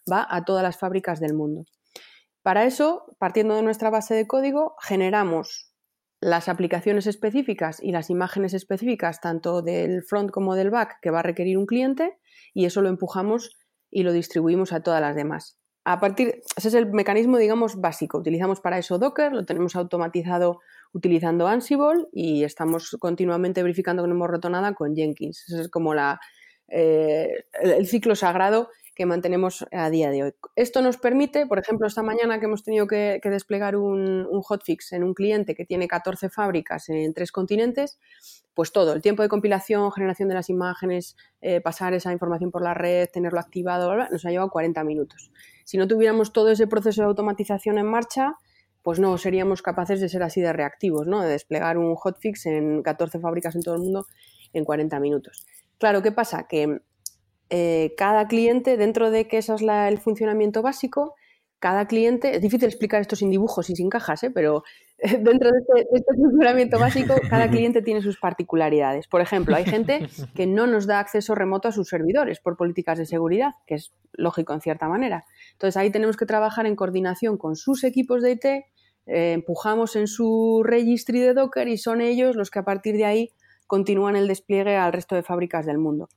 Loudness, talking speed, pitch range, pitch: -23 LUFS, 195 wpm, 170-220 Hz, 190 Hz